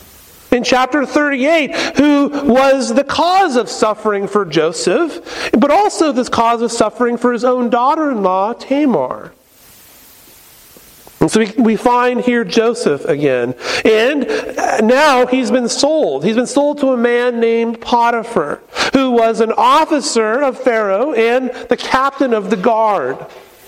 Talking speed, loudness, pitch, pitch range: 140 wpm, -14 LUFS, 245 Hz, 225-270 Hz